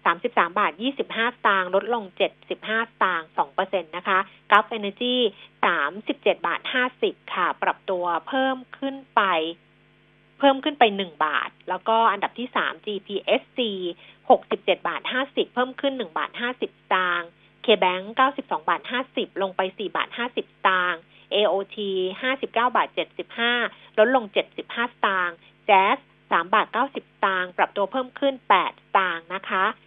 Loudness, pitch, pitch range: -24 LUFS, 210 Hz, 185-250 Hz